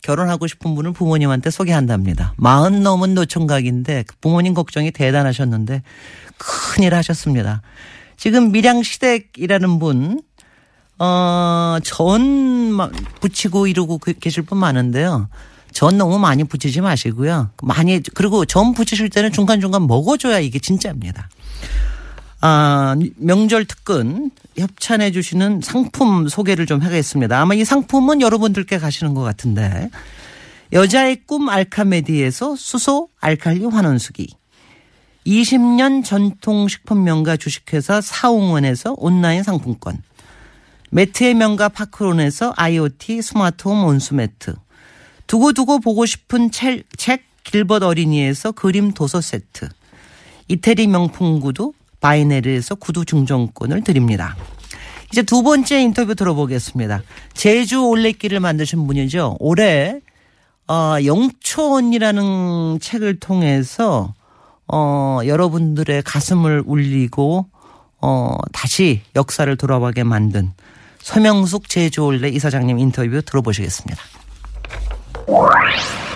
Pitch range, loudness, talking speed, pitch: 140-210 Hz, -16 LUFS, 275 characters per minute, 170 Hz